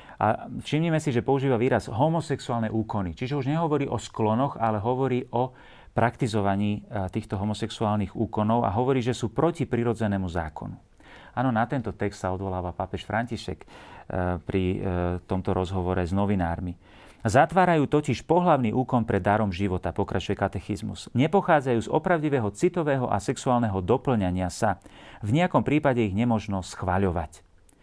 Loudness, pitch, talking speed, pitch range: -26 LUFS, 110 Hz, 135 wpm, 95-130 Hz